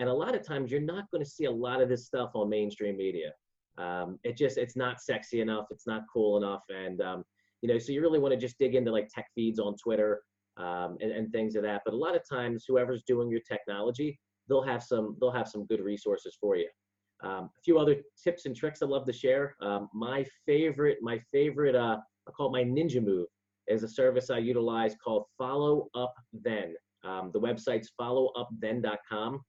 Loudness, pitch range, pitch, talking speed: -31 LUFS, 105-135 Hz, 120 Hz, 220 wpm